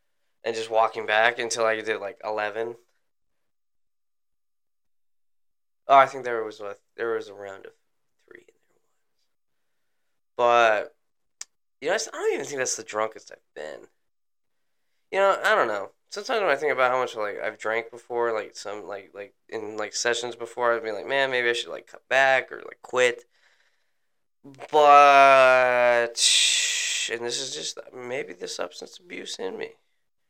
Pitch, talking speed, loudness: 135 Hz, 165 wpm, -22 LUFS